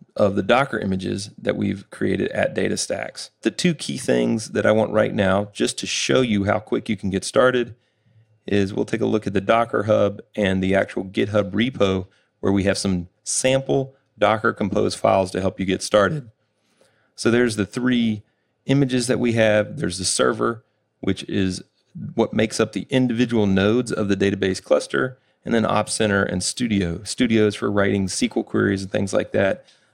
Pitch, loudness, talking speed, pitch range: 105 Hz, -21 LUFS, 185 wpm, 95-115 Hz